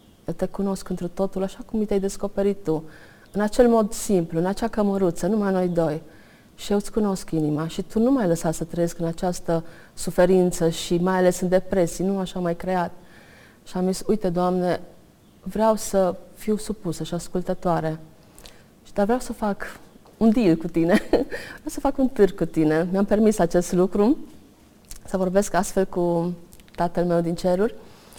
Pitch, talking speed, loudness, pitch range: 185 Hz, 175 wpm, -23 LUFS, 170-200 Hz